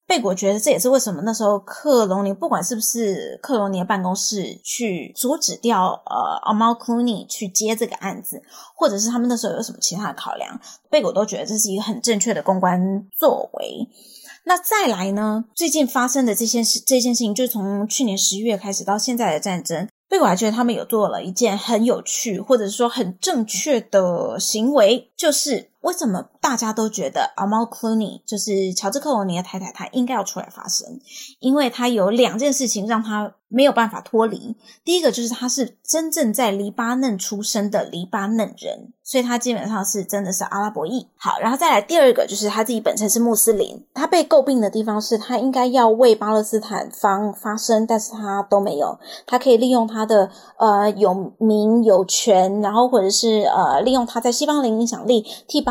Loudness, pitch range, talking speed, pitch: -19 LUFS, 205-245 Hz, 310 characters per minute, 225 Hz